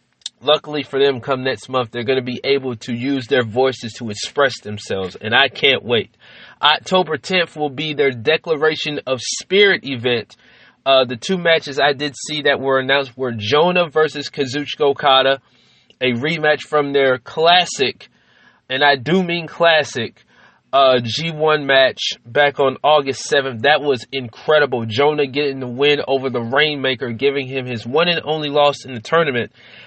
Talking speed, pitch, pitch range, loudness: 165 wpm, 140 Hz, 130-150 Hz, -17 LUFS